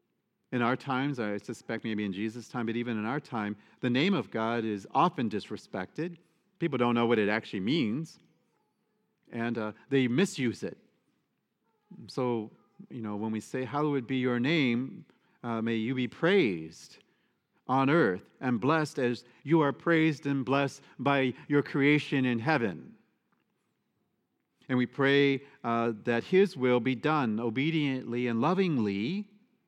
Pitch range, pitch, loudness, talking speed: 115-145 Hz, 130 Hz, -30 LUFS, 150 wpm